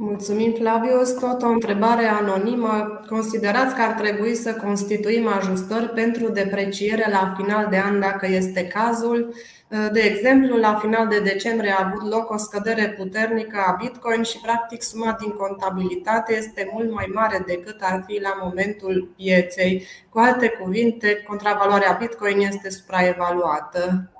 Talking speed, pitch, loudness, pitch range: 145 wpm, 210 Hz, -21 LUFS, 195-225 Hz